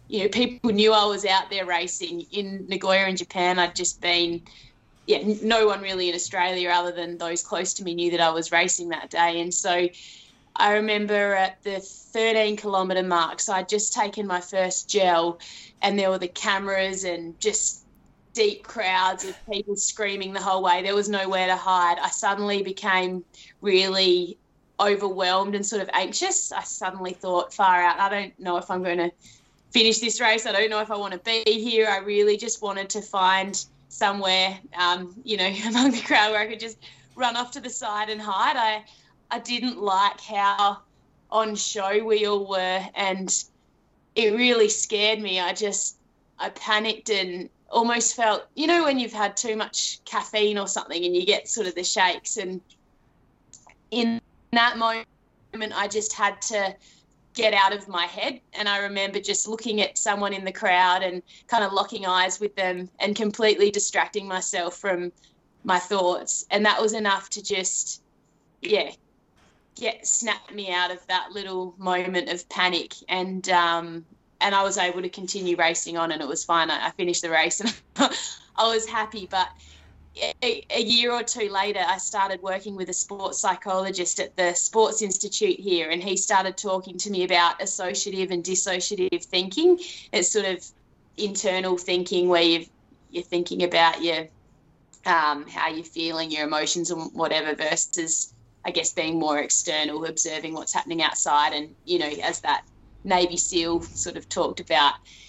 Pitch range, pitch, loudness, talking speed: 180-210 Hz, 190 Hz, -24 LUFS, 180 wpm